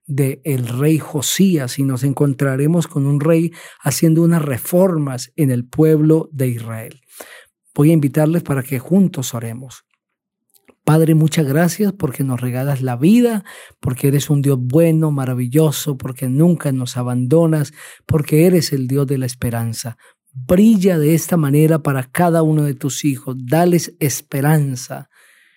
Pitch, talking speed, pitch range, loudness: 145 Hz, 145 wpm, 130-160 Hz, -16 LUFS